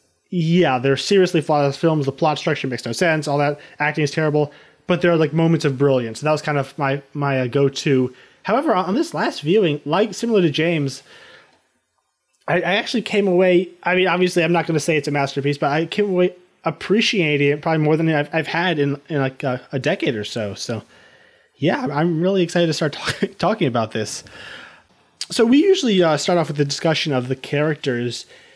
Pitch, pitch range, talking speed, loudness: 155 Hz, 140-175 Hz, 210 wpm, -19 LUFS